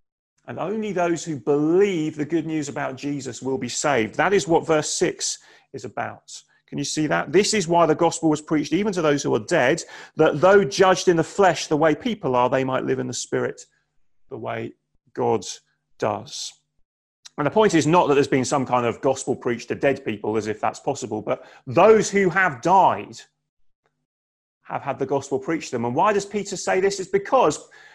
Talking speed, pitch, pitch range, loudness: 210 wpm, 160 Hz, 135-190 Hz, -21 LUFS